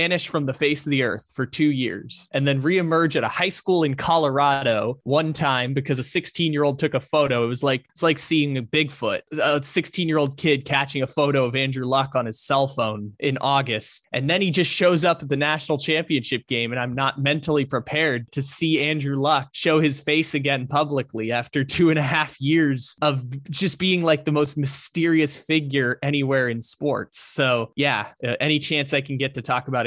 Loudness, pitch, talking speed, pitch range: -22 LUFS, 145 Hz, 205 wpm, 135-155 Hz